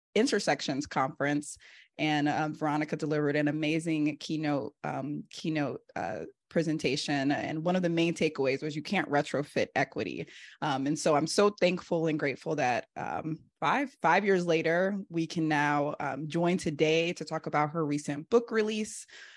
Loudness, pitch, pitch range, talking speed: -30 LUFS, 155 Hz, 150-170 Hz, 160 wpm